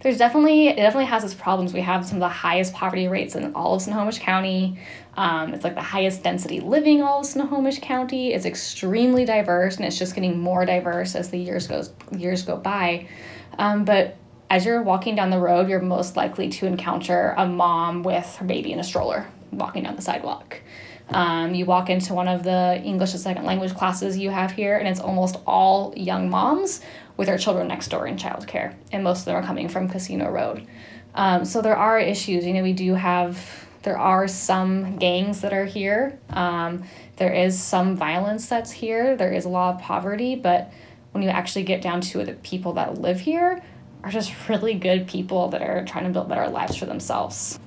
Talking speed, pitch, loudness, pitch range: 210 wpm, 185 Hz, -23 LUFS, 180-205 Hz